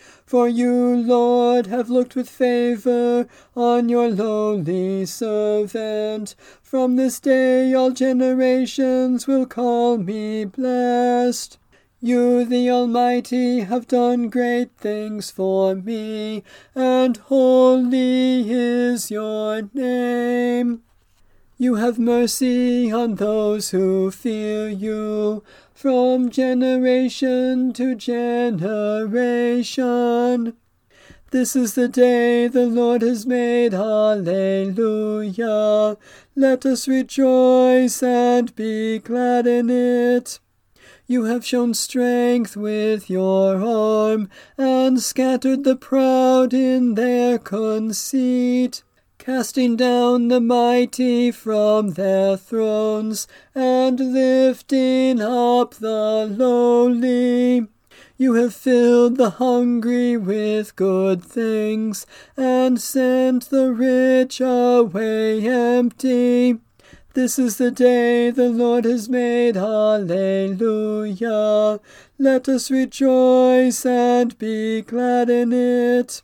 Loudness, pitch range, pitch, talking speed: -18 LUFS, 220-255 Hz, 245 Hz, 95 wpm